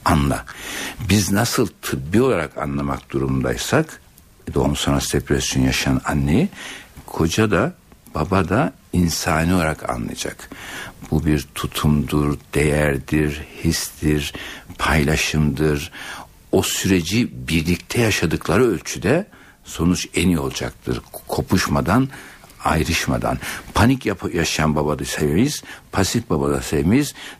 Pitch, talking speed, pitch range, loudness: 80 Hz, 95 wpm, 70-95 Hz, -20 LUFS